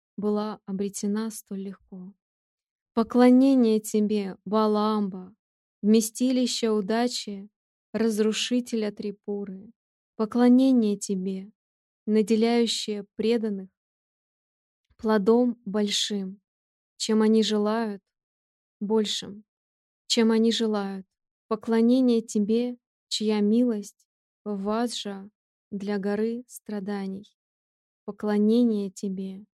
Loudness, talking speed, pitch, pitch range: -25 LUFS, 75 wpm, 215 Hz, 205-225 Hz